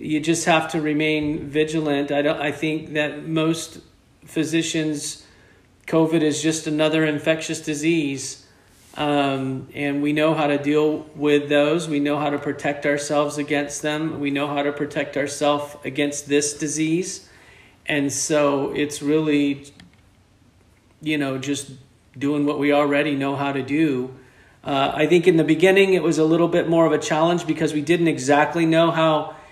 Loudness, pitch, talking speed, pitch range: -21 LUFS, 150 Hz, 165 wpm, 140-155 Hz